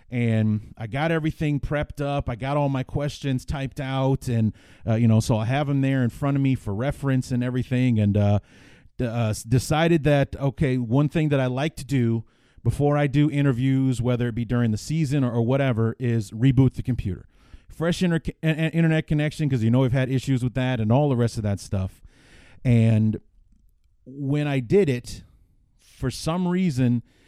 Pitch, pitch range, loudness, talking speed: 130 Hz, 115-145 Hz, -23 LUFS, 195 wpm